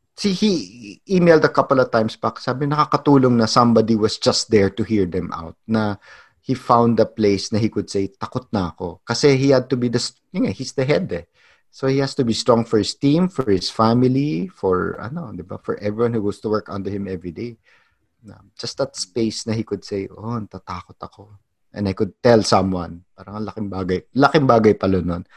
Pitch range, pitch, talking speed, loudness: 100-125 Hz, 110 Hz, 215 wpm, -19 LUFS